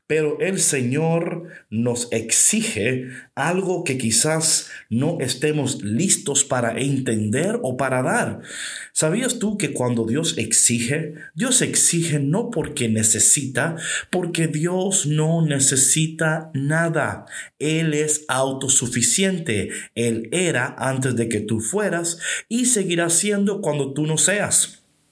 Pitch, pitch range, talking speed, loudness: 150 Hz, 130-170 Hz, 115 wpm, -19 LUFS